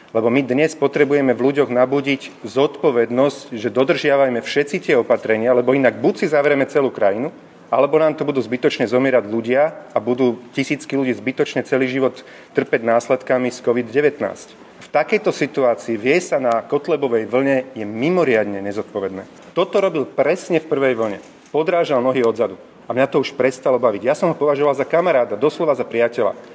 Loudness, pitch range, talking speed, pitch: -18 LUFS, 120-145 Hz, 165 wpm, 130 Hz